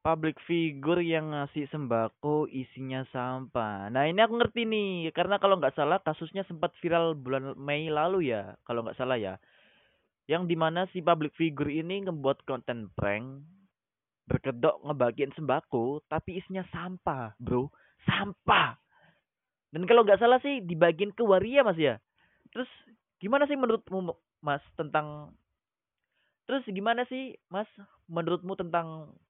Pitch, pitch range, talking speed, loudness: 160 Hz, 135-190 Hz, 135 wpm, -29 LUFS